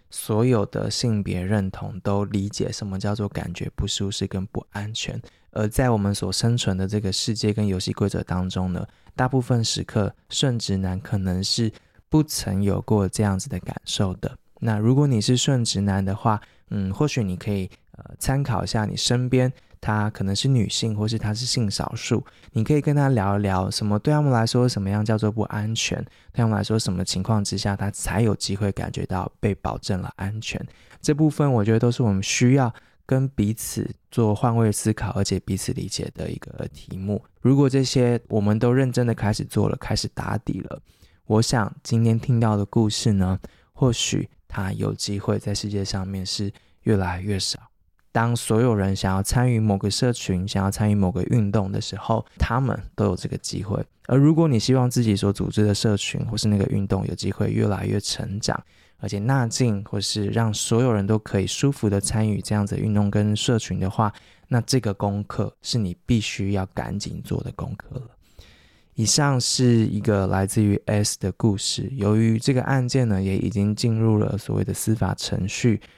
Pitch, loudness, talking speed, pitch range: 105 Hz, -23 LUFS, 285 characters per minute, 100-120 Hz